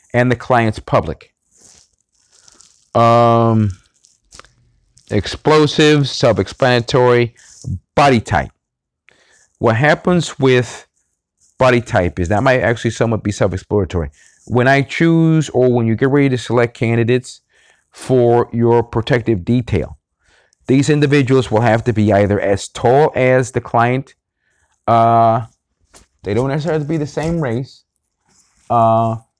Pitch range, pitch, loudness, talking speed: 115-135 Hz, 120 Hz, -15 LUFS, 120 wpm